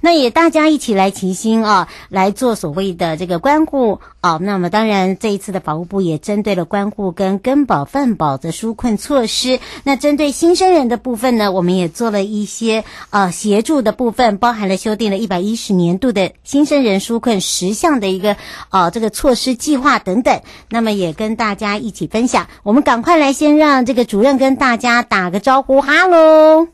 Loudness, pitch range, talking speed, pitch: -14 LUFS, 195-270 Hz, 300 characters per minute, 225 Hz